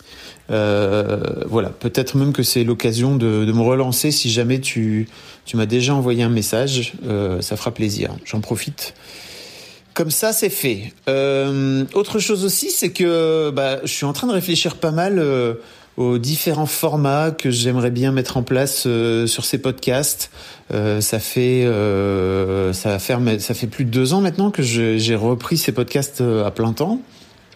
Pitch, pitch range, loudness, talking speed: 125 Hz, 115-145 Hz, -19 LUFS, 175 wpm